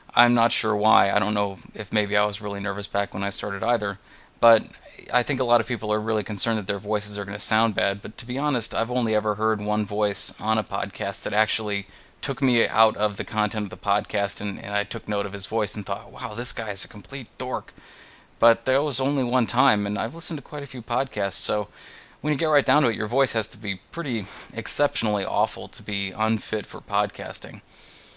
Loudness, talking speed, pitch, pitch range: -23 LUFS, 240 wpm, 105 Hz, 100-115 Hz